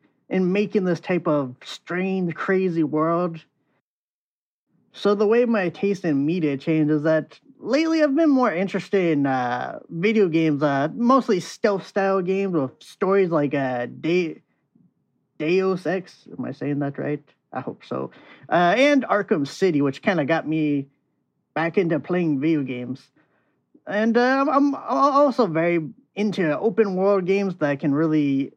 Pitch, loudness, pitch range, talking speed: 175 Hz, -22 LUFS, 150-200 Hz, 155 wpm